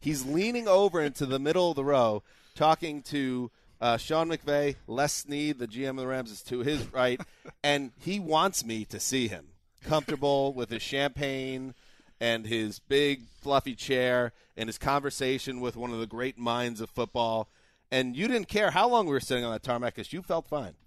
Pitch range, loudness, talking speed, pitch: 120-150 Hz, -29 LUFS, 195 wpm, 130 Hz